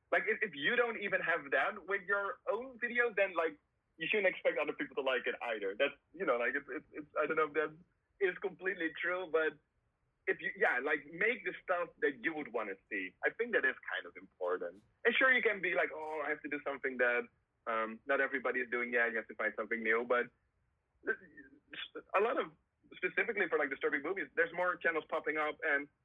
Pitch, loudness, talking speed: 165 Hz, -35 LUFS, 225 wpm